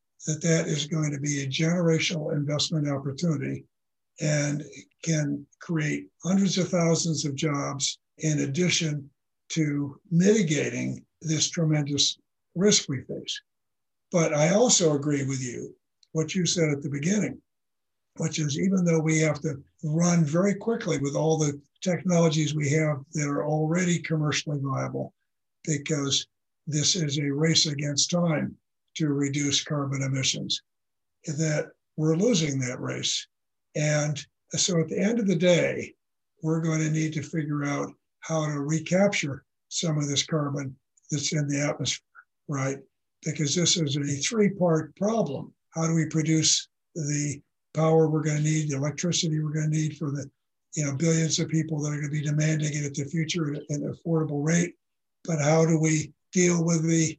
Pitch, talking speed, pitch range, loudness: 155 Hz, 160 wpm, 145-165 Hz, -26 LUFS